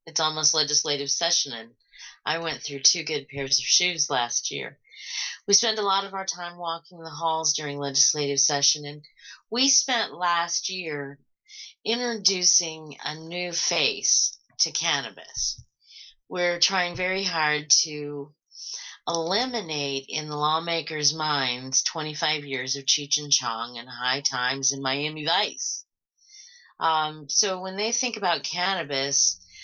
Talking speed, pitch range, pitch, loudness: 140 wpm, 140-180 Hz, 155 Hz, -24 LUFS